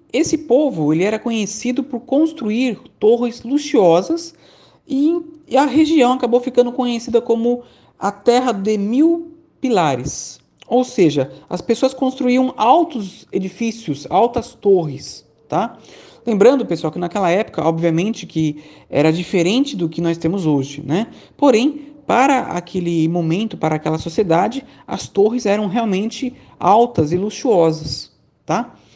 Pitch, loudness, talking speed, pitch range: 230 Hz, -17 LUFS, 125 wpm, 175-260 Hz